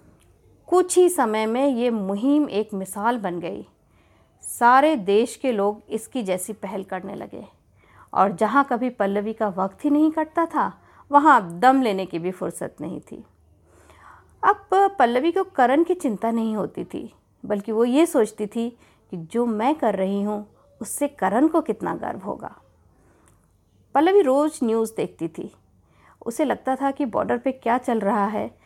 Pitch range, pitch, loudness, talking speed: 195-275 Hz, 230 Hz, -22 LUFS, 165 wpm